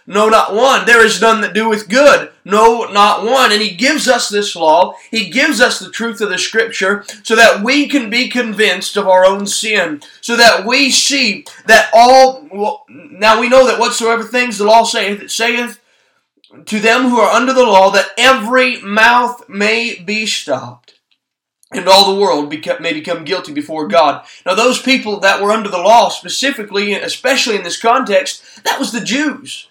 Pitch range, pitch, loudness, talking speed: 205-255 Hz, 225 Hz, -11 LUFS, 190 wpm